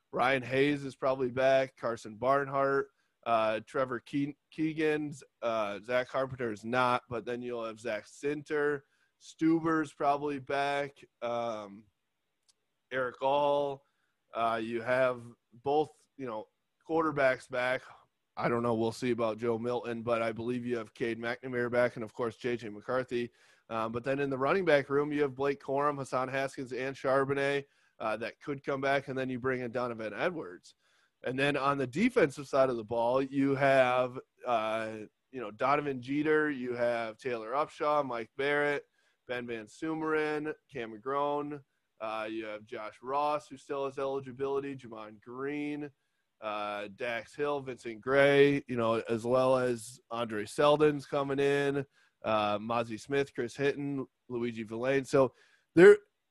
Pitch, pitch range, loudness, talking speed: 130 Hz, 120-140 Hz, -31 LUFS, 155 wpm